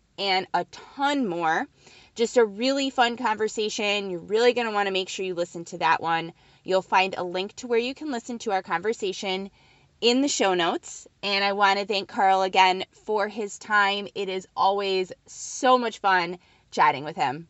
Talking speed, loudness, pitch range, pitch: 190 wpm, -25 LUFS, 185-225 Hz, 200 Hz